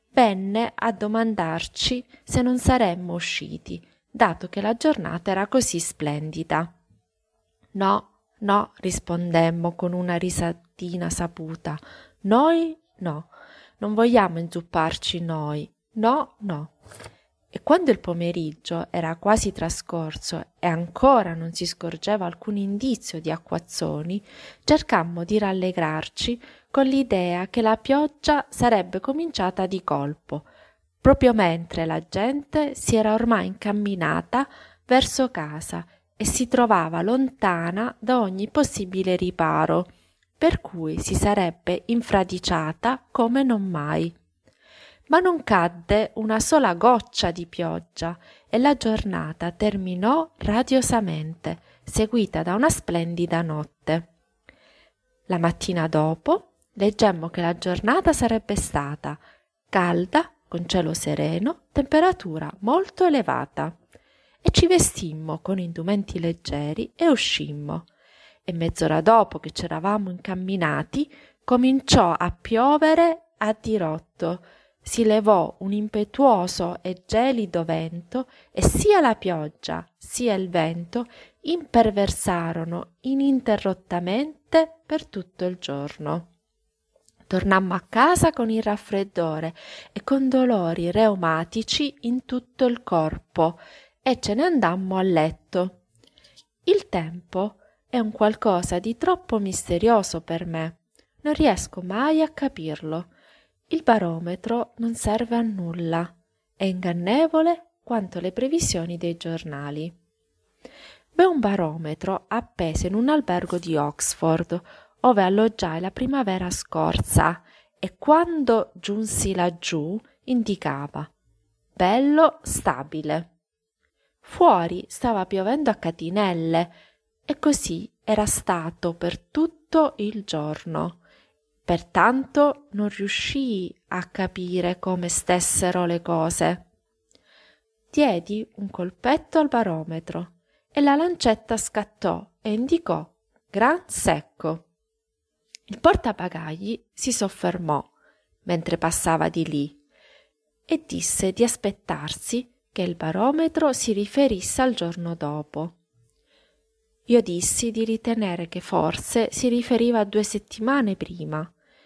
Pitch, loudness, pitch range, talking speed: 195 Hz, -23 LUFS, 170-245 Hz, 110 wpm